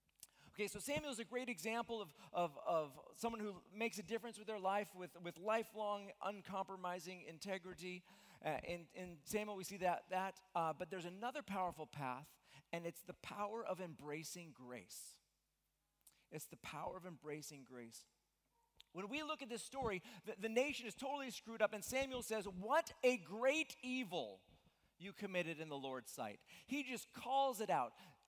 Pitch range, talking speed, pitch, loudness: 165-230 Hz, 170 wpm, 190 Hz, -45 LUFS